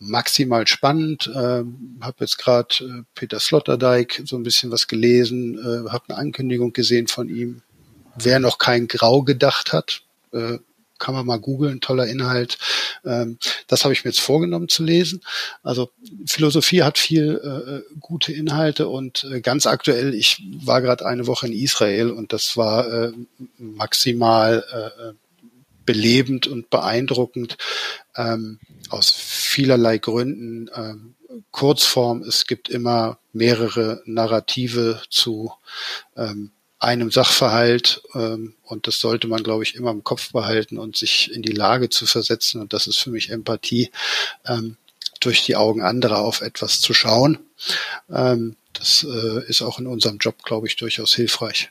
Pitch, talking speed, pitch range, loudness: 120 Hz, 150 wpm, 115-130 Hz, -19 LUFS